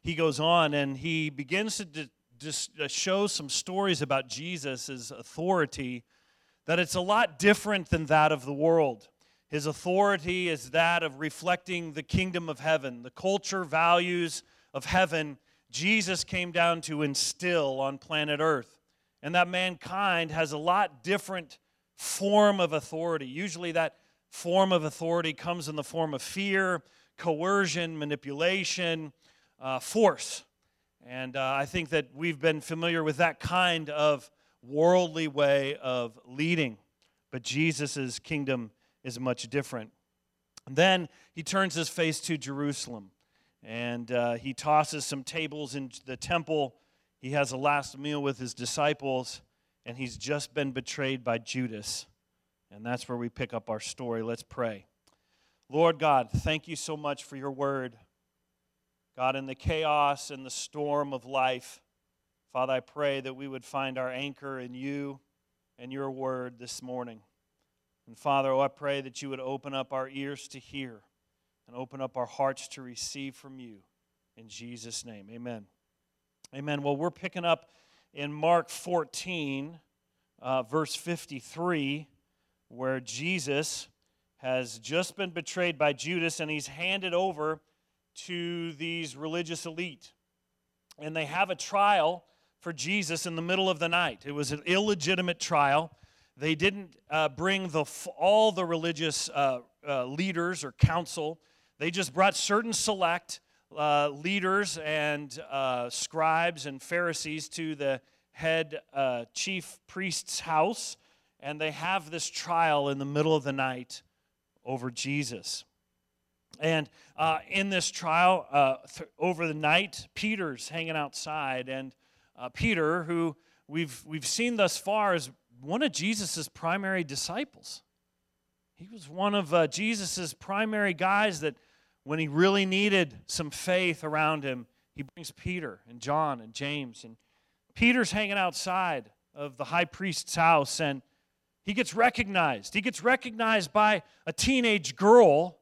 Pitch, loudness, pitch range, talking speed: 155 Hz, -29 LUFS, 130-175 Hz, 150 wpm